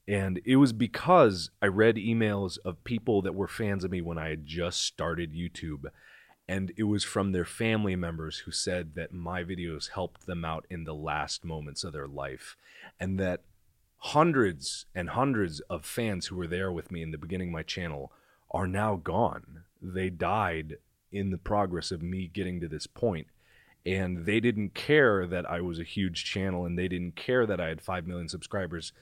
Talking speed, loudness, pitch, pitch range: 195 wpm, -30 LUFS, 90 Hz, 85-100 Hz